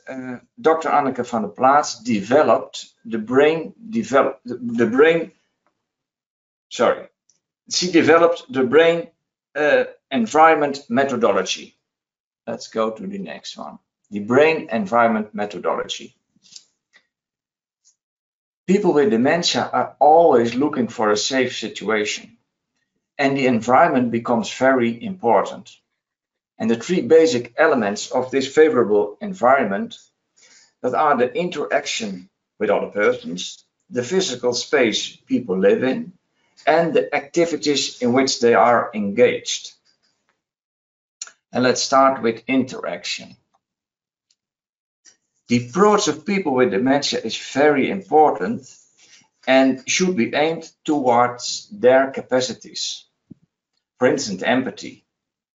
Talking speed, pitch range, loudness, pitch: 110 wpm, 120-170 Hz, -19 LUFS, 135 Hz